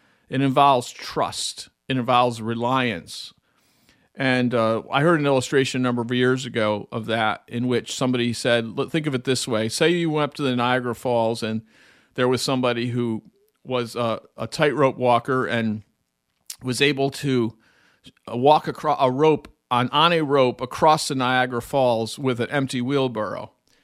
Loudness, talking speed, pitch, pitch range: -22 LUFS, 165 wpm, 125 Hz, 115-135 Hz